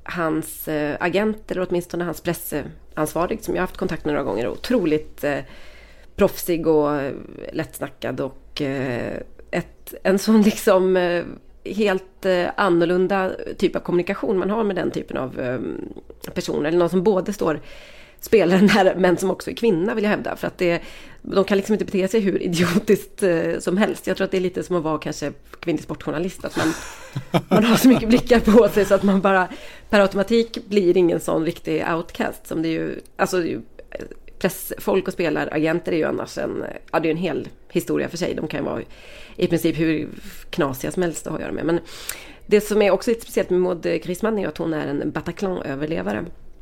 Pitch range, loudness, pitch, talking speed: 165-200 Hz, -21 LUFS, 180 Hz, 190 wpm